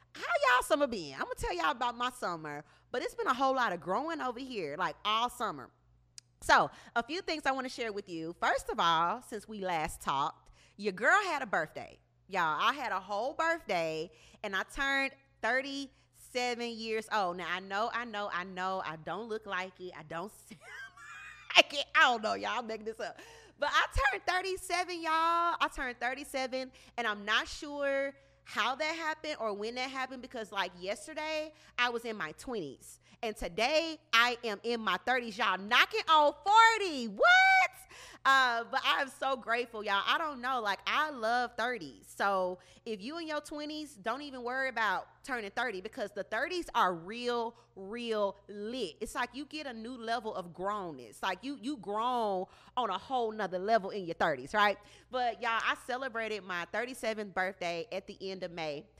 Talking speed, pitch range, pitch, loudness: 190 wpm, 200-280 Hz, 235 Hz, -32 LUFS